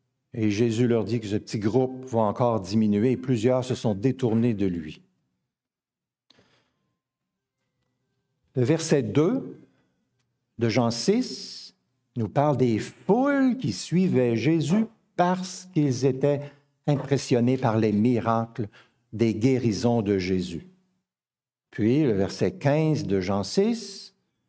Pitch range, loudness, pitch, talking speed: 115-150 Hz, -25 LUFS, 125 Hz, 120 wpm